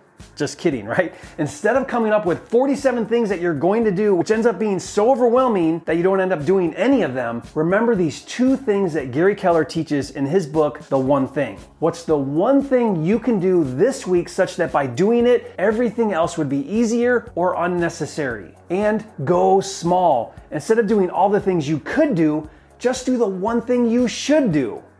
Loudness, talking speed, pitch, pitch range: -19 LUFS, 205 wpm, 190 Hz, 160-235 Hz